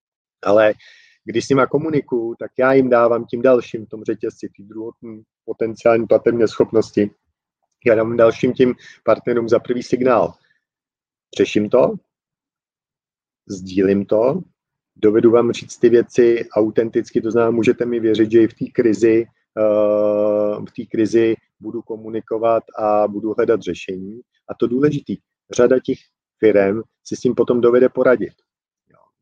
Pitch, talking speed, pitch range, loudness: 115 Hz, 140 wpm, 110-125 Hz, -17 LUFS